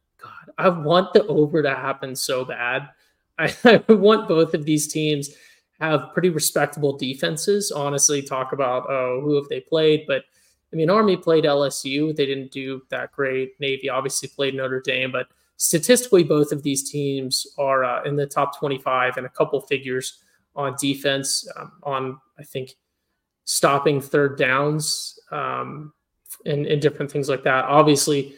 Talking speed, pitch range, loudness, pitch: 160 wpm, 135-155 Hz, -21 LUFS, 145 Hz